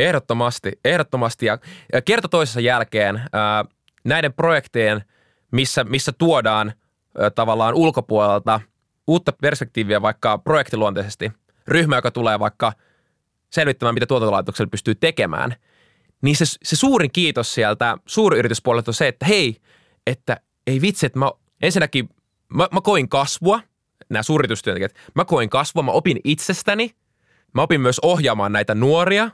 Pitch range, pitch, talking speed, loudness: 110-160 Hz, 130 Hz, 125 wpm, -19 LUFS